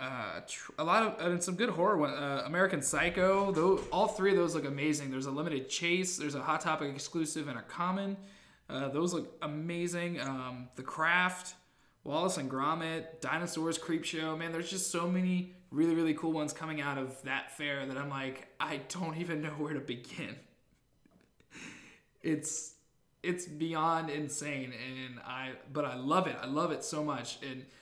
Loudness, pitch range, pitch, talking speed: -34 LUFS, 140-175 Hz, 155 Hz, 185 wpm